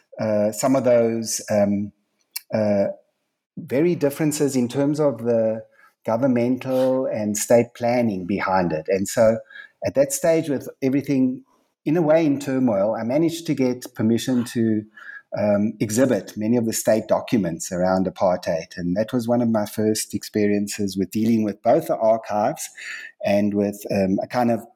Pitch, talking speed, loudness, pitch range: 115 Hz, 160 wpm, -21 LUFS, 105-130 Hz